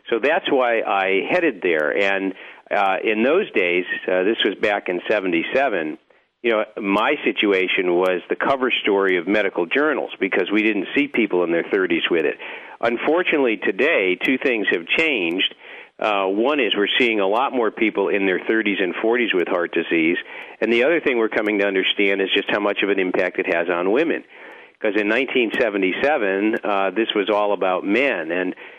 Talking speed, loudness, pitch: 190 wpm, -19 LUFS, 110 Hz